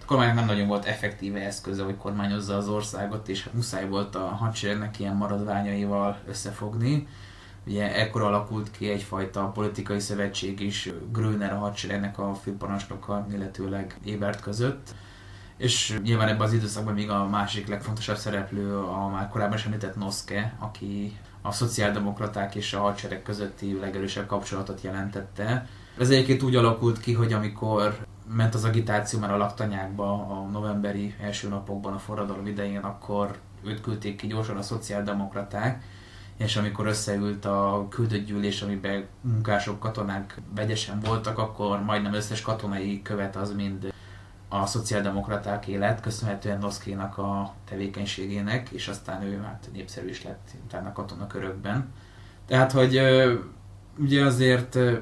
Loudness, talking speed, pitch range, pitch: -28 LUFS, 135 wpm, 100-110 Hz, 100 Hz